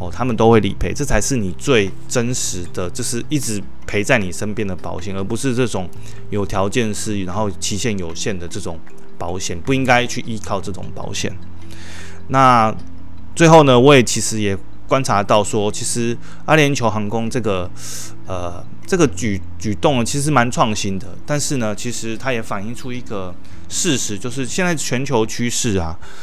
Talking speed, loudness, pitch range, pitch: 260 characters per minute, -18 LUFS, 95-120 Hz, 105 Hz